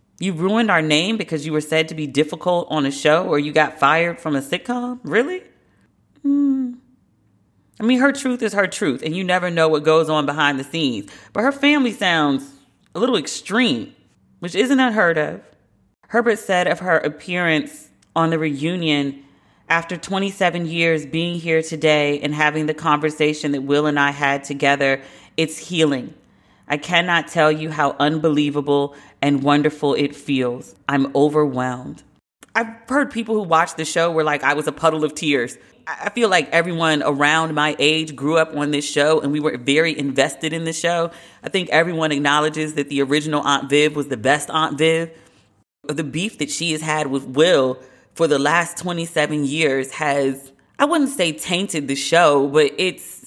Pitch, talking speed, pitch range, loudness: 155 Hz, 180 wpm, 145-175 Hz, -19 LUFS